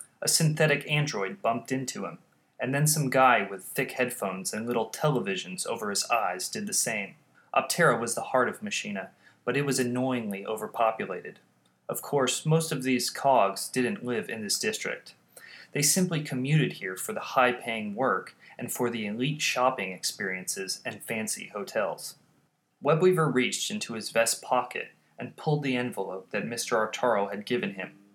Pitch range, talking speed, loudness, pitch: 110-150 Hz, 165 wpm, -28 LUFS, 130 Hz